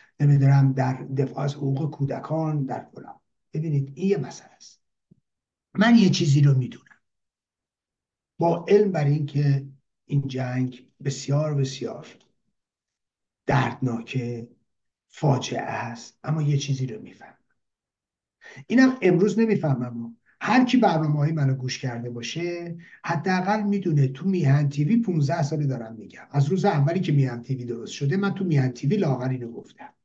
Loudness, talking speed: -24 LUFS, 140 wpm